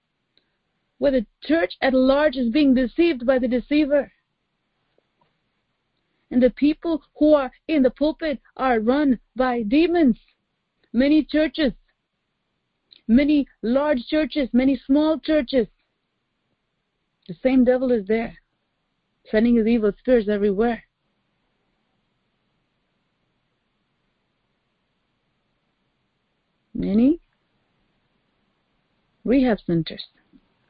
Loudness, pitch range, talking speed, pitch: -21 LUFS, 235-295 Hz, 85 wpm, 260 Hz